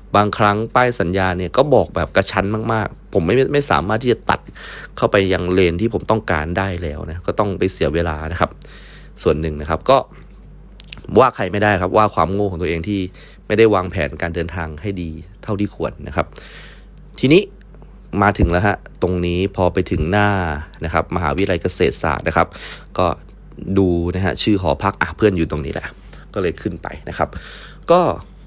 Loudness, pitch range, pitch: -18 LUFS, 85-105 Hz, 95 Hz